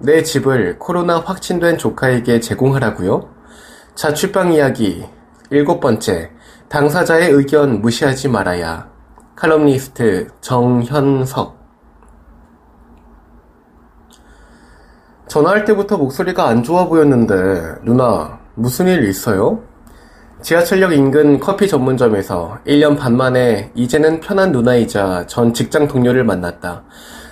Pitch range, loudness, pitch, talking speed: 115-155 Hz, -14 LUFS, 130 Hz, 240 characters per minute